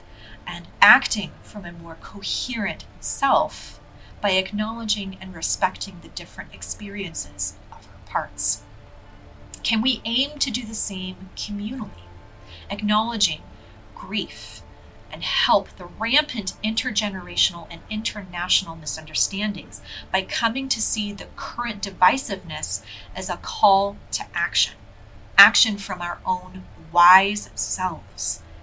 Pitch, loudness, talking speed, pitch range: 195 Hz, -22 LUFS, 110 wpm, 170-215 Hz